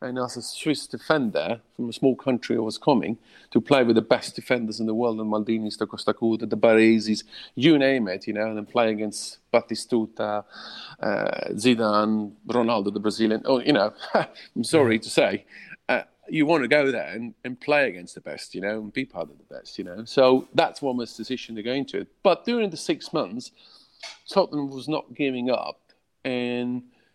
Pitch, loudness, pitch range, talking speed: 120 Hz, -24 LUFS, 110-130 Hz, 200 wpm